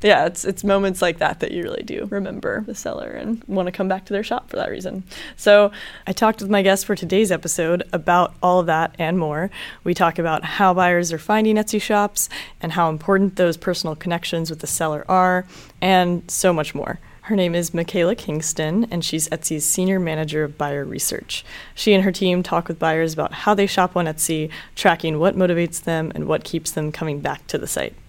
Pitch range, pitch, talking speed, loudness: 160-195 Hz, 180 Hz, 215 wpm, -20 LUFS